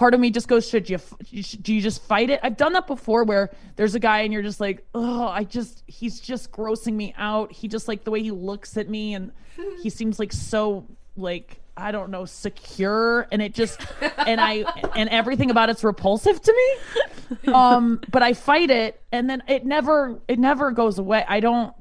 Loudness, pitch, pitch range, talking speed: -22 LUFS, 225 Hz, 210-245 Hz, 215 wpm